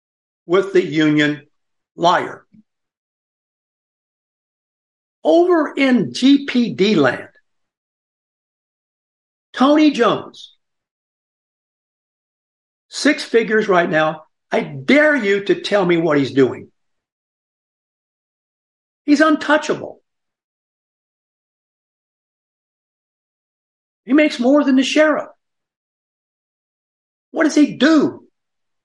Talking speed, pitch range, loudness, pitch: 75 wpm, 195-300 Hz, -16 LUFS, 270 Hz